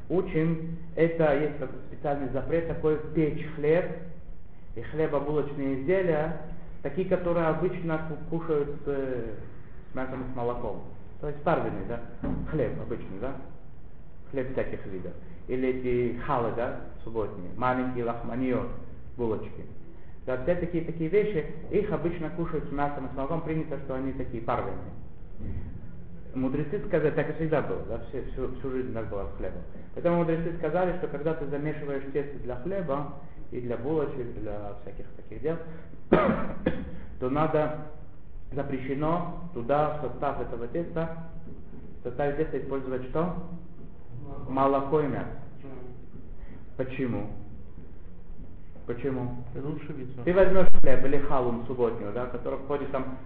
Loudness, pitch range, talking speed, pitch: -30 LUFS, 120-155 Hz, 130 wpm, 135 Hz